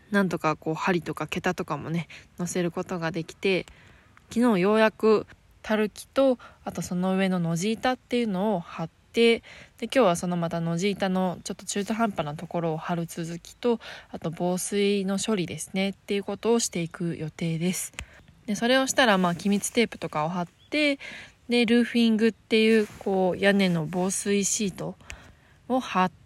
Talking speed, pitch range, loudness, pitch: 355 characters per minute, 175-225 Hz, -26 LUFS, 195 Hz